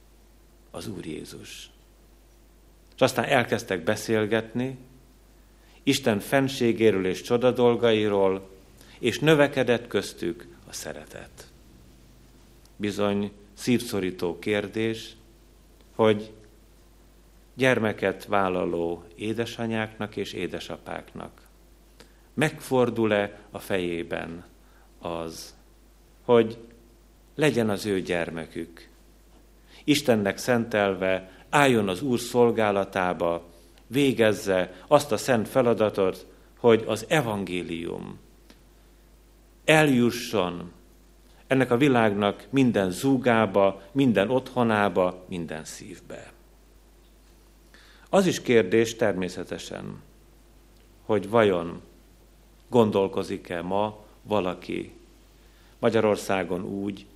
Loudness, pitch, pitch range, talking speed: -25 LUFS, 105 Hz, 90-120 Hz, 70 wpm